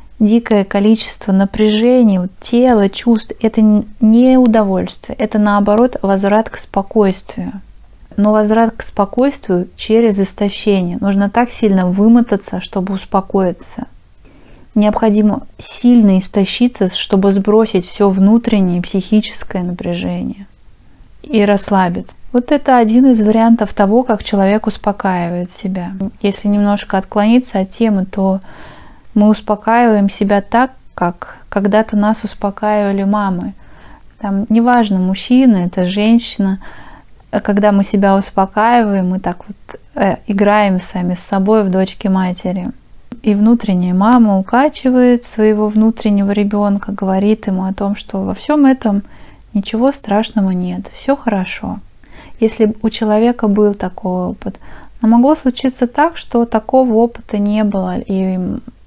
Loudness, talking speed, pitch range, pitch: -13 LUFS, 120 wpm, 195-225 Hz, 210 Hz